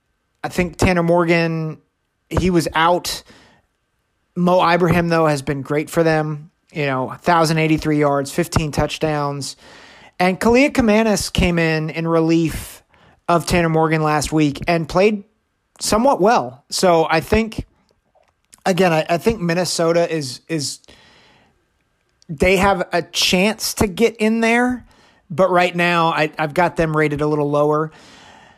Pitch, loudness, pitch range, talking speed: 165 Hz, -17 LUFS, 155-180 Hz, 140 wpm